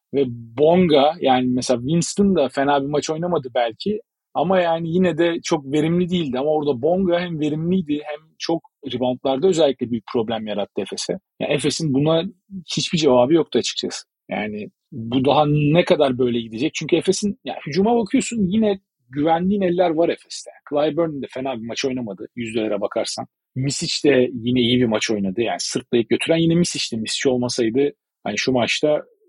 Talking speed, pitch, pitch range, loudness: 165 wpm, 150 Hz, 130-170 Hz, -20 LUFS